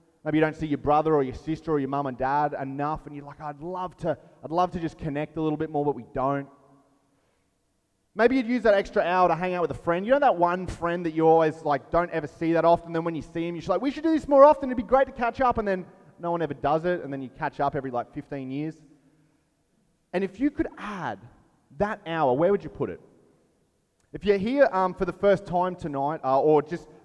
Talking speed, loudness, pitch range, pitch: 260 wpm, -25 LUFS, 145-180 Hz, 160 Hz